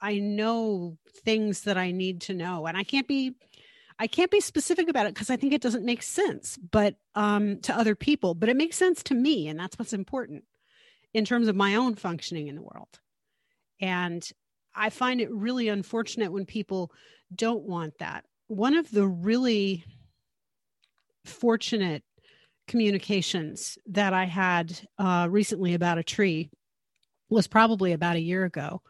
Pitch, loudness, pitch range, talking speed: 210 Hz, -27 LUFS, 185-235 Hz, 165 wpm